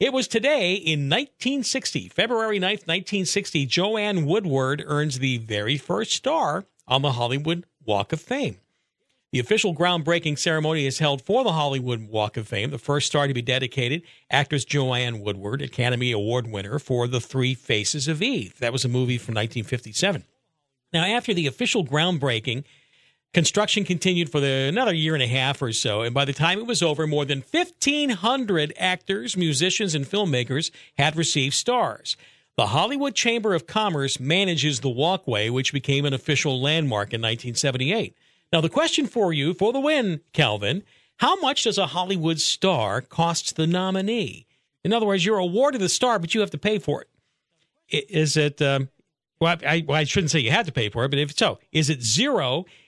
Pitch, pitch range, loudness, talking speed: 155 Hz, 135-190 Hz, -23 LUFS, 180 wpm